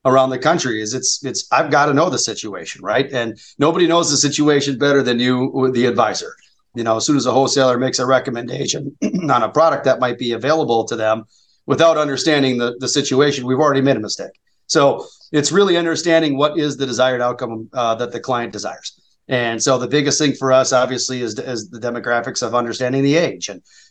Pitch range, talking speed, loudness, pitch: 120-145 Hz, 210 wpm, -17 LUFS, 130 Hz